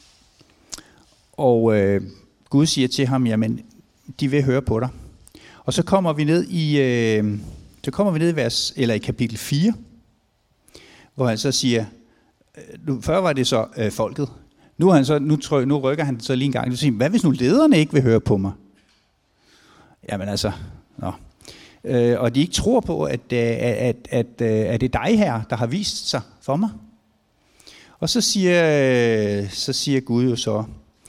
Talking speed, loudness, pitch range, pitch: 185 wpm, -20 LUFS, 110-145 Hz, 125 Hz